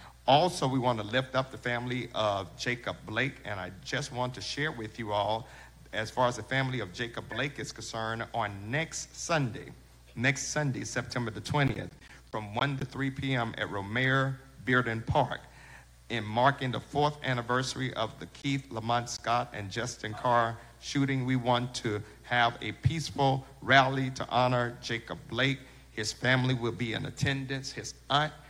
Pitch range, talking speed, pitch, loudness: 115-135 Hz, 170 wpm, 125 Hz, -31 LUFS